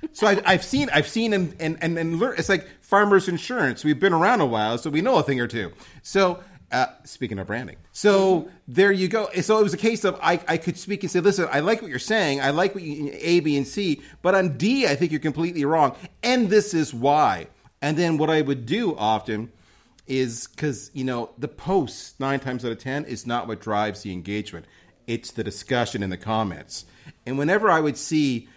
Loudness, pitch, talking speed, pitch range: -23 LUFS, 150 Hz, 225 wpm, 120-190 Hz